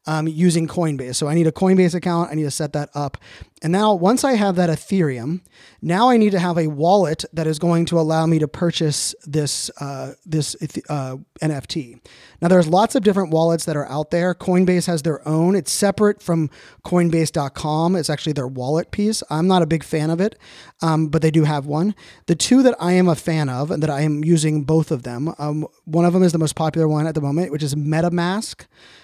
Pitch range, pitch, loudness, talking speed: 150-180 Hz, 160 Hz, -19 LUFS, 225 wpm